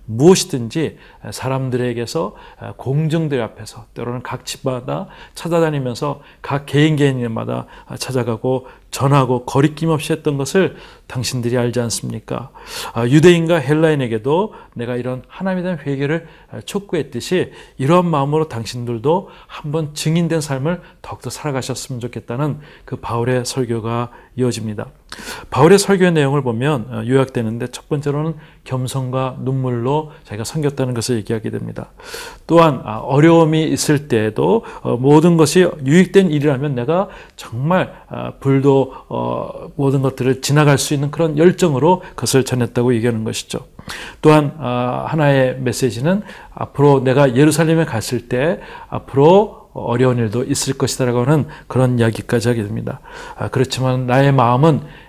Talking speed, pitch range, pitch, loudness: 320 characters per minute, 120-155 Hz, 135 Hz, -17 LUFS